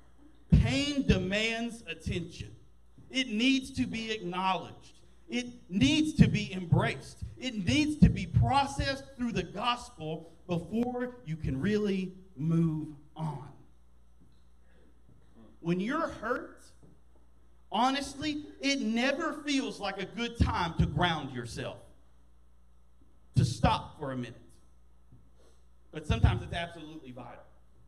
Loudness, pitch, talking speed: -31 LUFS, 175 Hz, 110 wpm